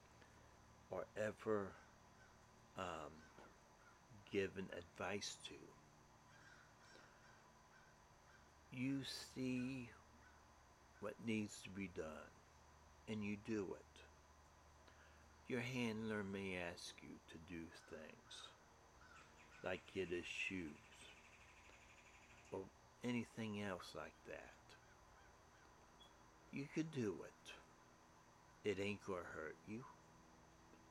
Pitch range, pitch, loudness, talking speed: 80-110 Hz, 90 Hz, -49 LUFS, 85 wpm